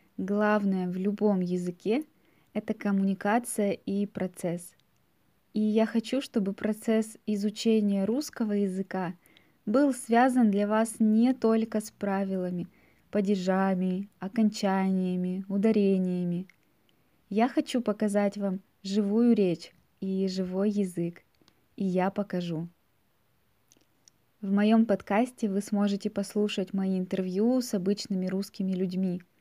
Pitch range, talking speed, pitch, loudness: 190-220 Hz, 105 wpm, 200 Hz, -28 LUFS